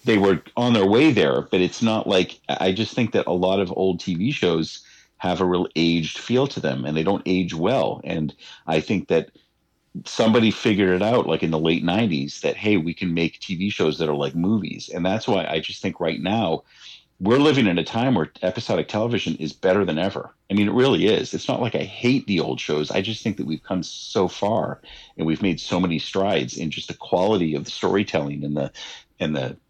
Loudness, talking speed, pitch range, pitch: -22 LUFS, 230 wpm, 80-105 Hz, 90 Hz